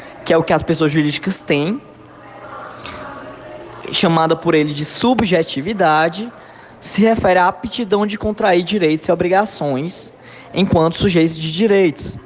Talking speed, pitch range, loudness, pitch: 125 wpm, 155-200 Hz, -16 LUFS, 170 Hz